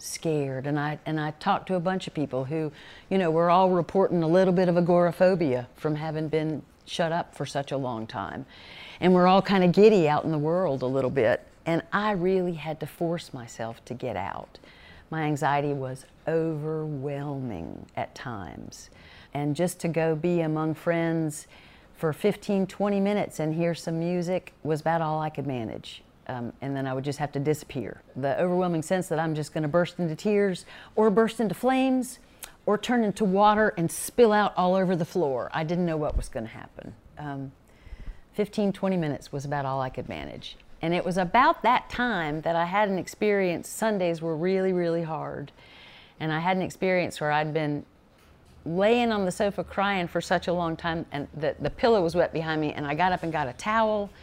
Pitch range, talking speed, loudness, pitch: 150-185 Hz, 205 wpm, -26 LUFS, 165 Hz